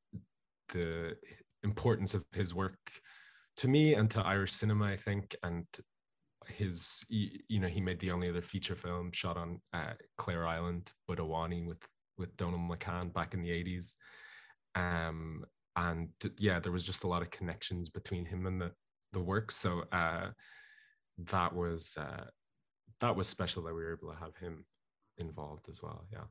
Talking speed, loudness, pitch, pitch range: 165 wpm, -37 LUFS, 90 Hz, 85-100 Hz